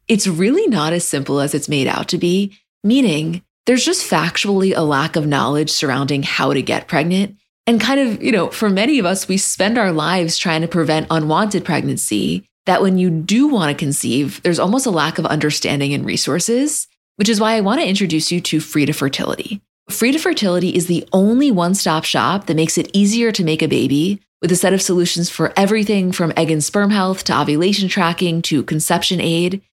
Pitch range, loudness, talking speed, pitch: 160-200 Hz, -16 LUFS, 210 wpm, 180 Hz